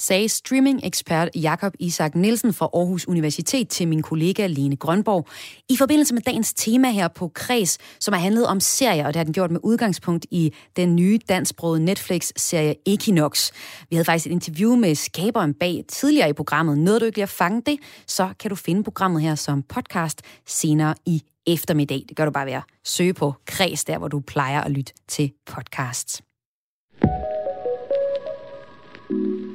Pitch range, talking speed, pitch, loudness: 150-210 Hz, 170 wpm, 170 Hz, -21 LUFS